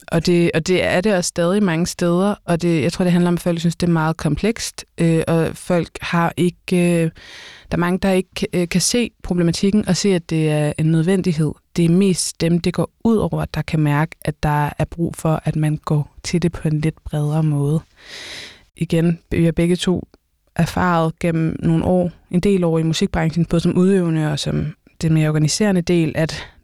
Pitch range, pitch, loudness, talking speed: 160-180 Hz, 170 Hz, -18 LUFS, 215 wpm